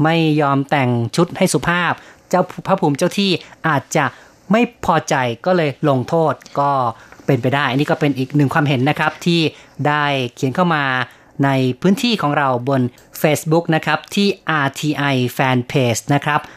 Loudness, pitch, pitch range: -17 LUFS, 150 Hz, 135-165 Hz